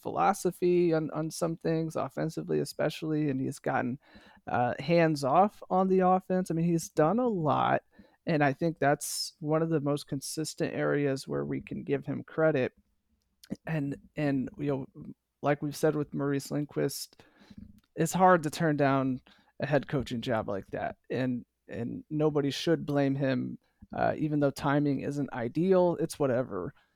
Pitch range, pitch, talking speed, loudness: 135-165 Hz, 150 Hz, 160 wpm, -30 LUFS